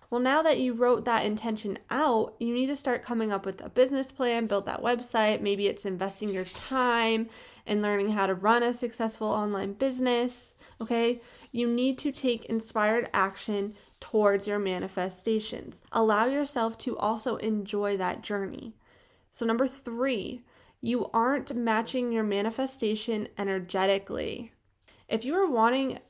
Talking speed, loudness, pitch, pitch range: 150 wpm, -28 LUFS, 225 Hz, 205-245 Hz